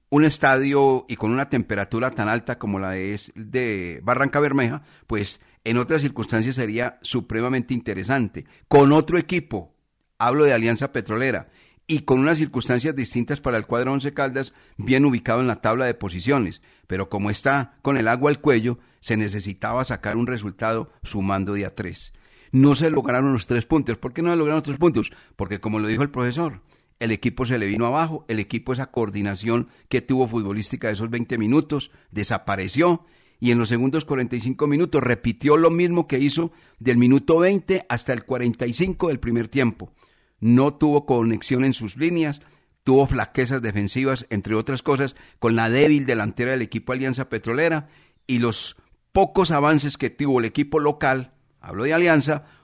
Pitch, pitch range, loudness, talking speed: 125 Hz, 110-145 Hz, -22 LUFS, 175 wpm